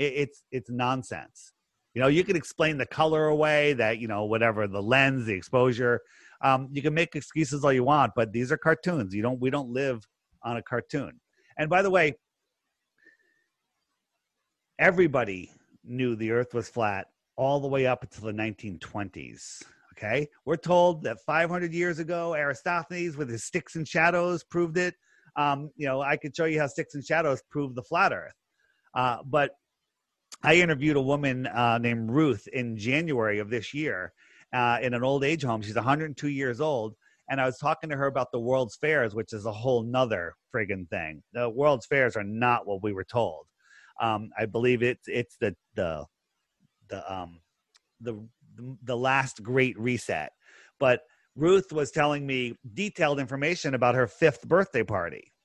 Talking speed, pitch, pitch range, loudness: 175 wpm, 130 Hz, 120-155 Hz, -27 LUFS